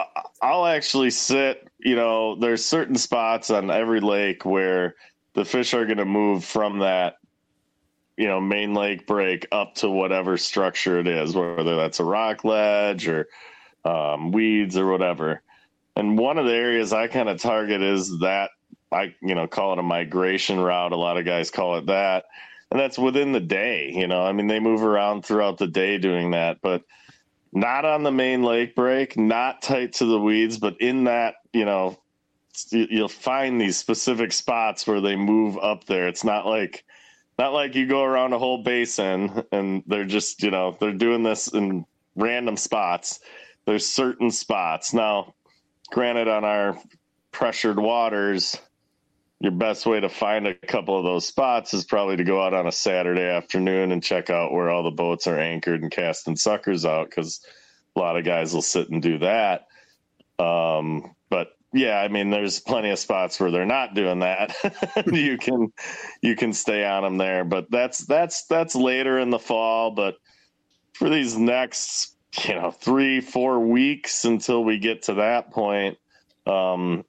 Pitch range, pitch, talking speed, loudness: 95-120 Hz, 105 Hz, 180 wpm, -23 LUFS